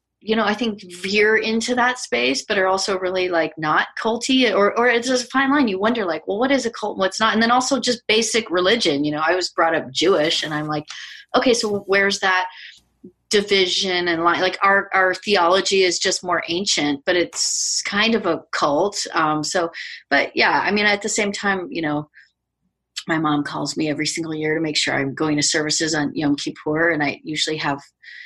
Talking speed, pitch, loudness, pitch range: 220 wpm, 190 Hz, -19 LUFS, 155-220 Hz